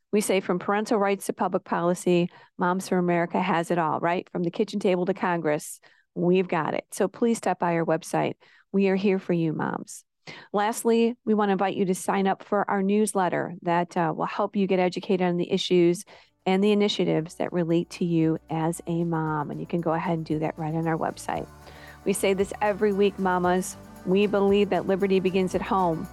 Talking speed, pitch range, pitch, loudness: 215 wpm, 170-200 Hz, 185 Hz, -25 LUFS